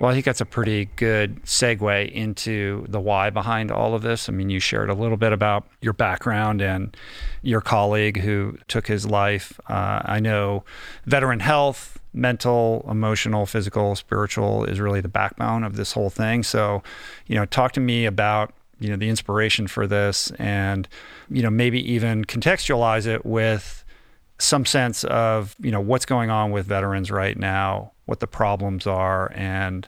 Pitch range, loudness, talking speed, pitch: 100-115 Hz, -22 LUFS, 175 wpm, 105 Hz